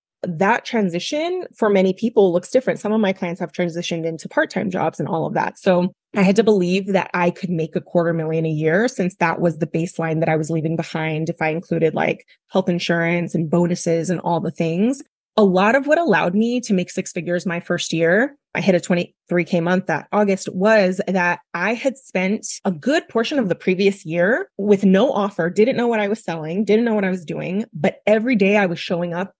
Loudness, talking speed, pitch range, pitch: -19 LUFS, 225 wpm, 170-210 Hz, 185 Hz